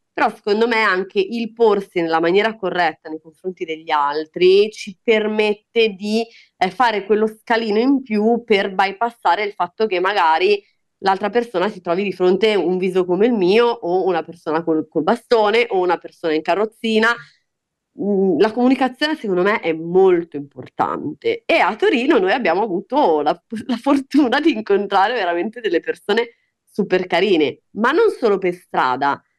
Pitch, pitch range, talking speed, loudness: 205 Hz, 175-230 Hz, 160 wpm, -18 LUFS